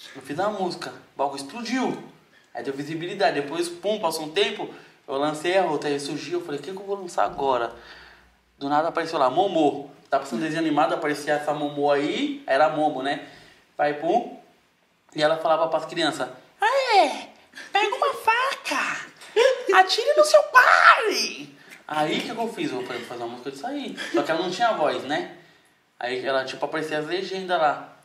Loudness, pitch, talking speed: -23 LUFS, 165 Hz, 195 wpm